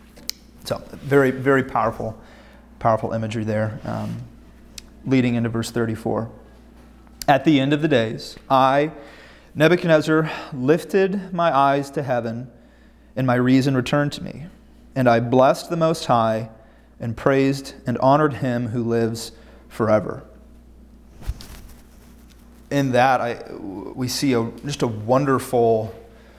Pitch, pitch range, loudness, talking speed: 125 Hz, 115-140 Hz, -20 LUFS, 125 wpm